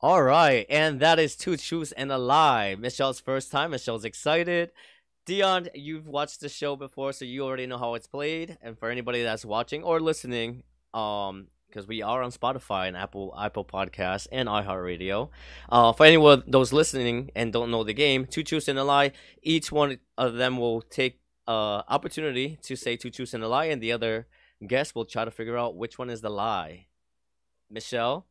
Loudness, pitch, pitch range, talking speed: -26 LUFS, 125 Hz, 110-145 Hz, 195 wpm